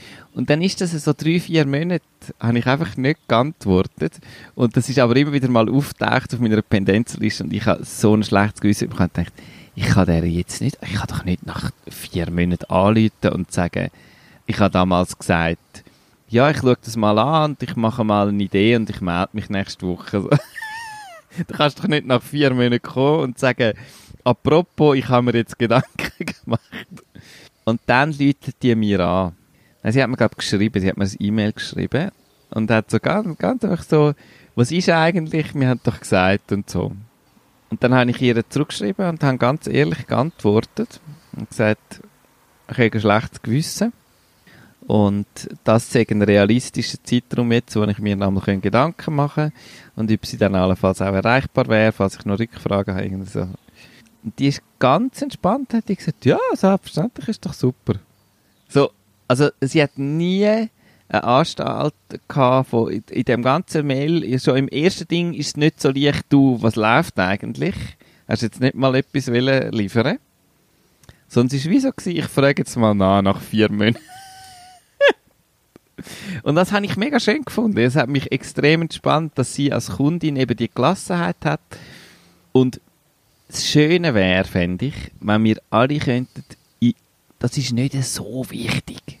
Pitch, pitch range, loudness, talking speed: 125 Hz, 105-150 Hz, -19 LUFS, 180 wpm